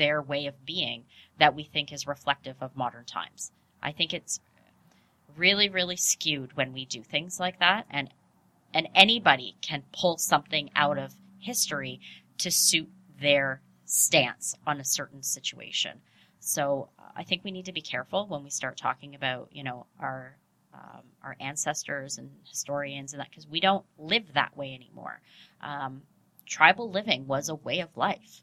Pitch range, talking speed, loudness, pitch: 135-180 Hz, 165 wpm, -27 LUFS, 145 Hz